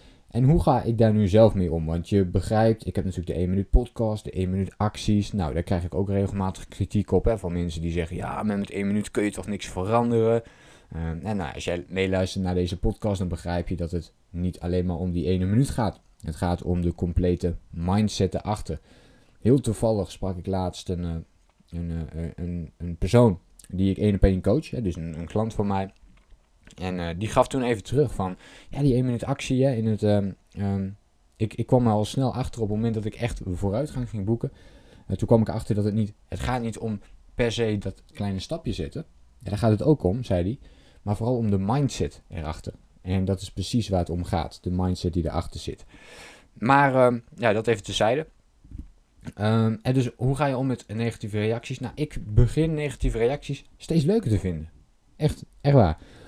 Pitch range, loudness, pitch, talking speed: 90-115 Hz, -25 LUFS, 100 Hz, 215 wpm